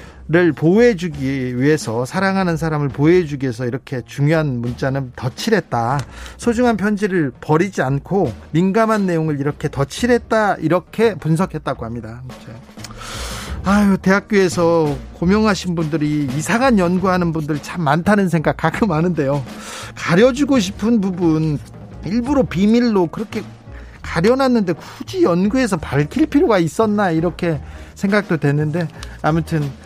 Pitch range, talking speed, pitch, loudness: 140-200 Hz, 310 characters per minute, 170 Hz, -17 LUFS